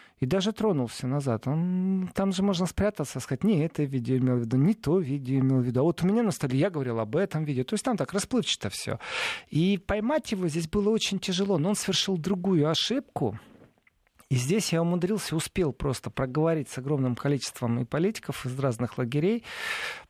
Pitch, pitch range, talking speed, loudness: 165 Hz, 135-200 Hz, 195 wpm, -27 LUFS